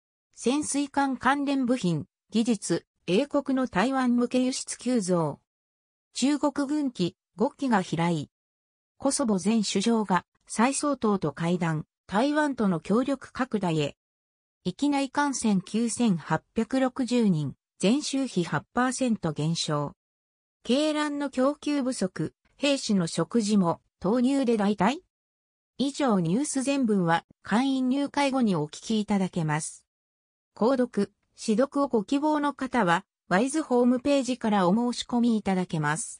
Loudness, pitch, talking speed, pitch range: -27 LUFS, 225 Hz, 230 characters per minute, 170-265 Hz